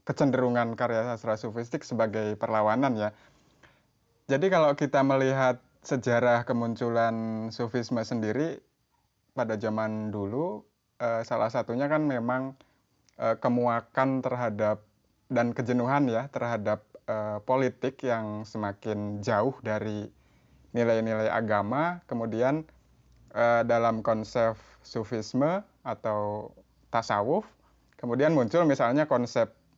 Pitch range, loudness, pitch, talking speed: 110-130 Hz, -28 LUFS, 115 Hz, 90 wpm